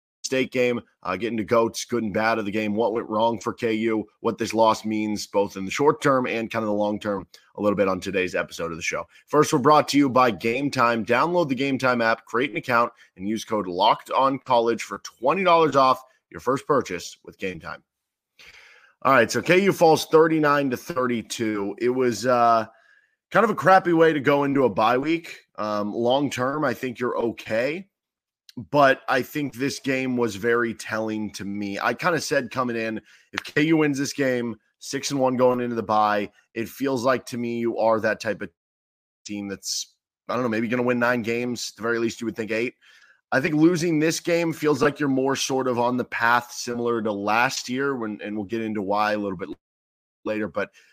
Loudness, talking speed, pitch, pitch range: -23 LUFS, 225 wpm, 120 Hz, 110-135 Hz